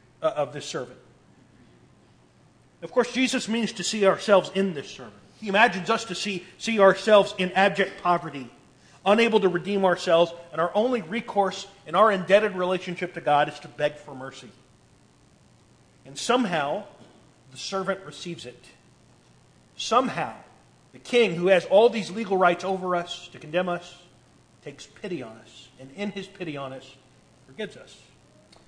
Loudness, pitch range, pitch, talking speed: -24 LUFS, 135-195 Hz, 175 Hz, 155 wpm